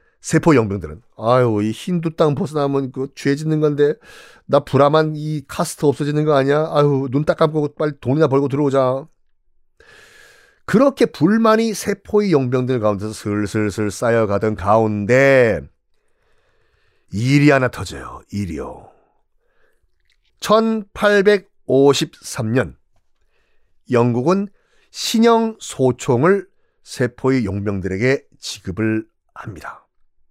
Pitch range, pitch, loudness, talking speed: 120-185 Hz, 140 Hz, -17 LUFS, 230 characters per minute